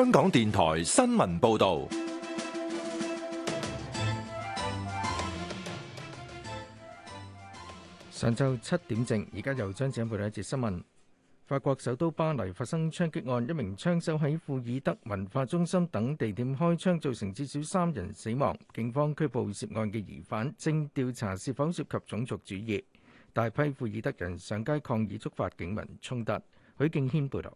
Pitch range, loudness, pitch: 105-150 Hz, -31 LUFS, 120 Hz